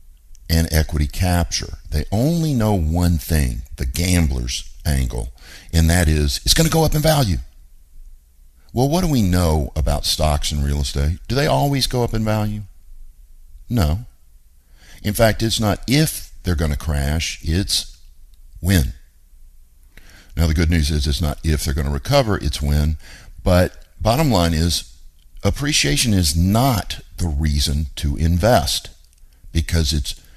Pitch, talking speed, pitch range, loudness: 80 Hz, 150 wpm, 70-95 Hz, -19 LUFS